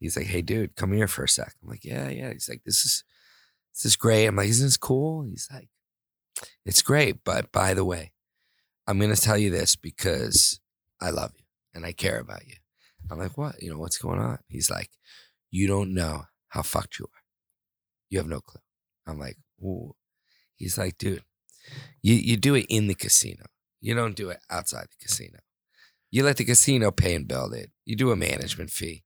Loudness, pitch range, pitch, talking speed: -24 LUFS, 90-115 Hz, 100 Hz, 210 wpm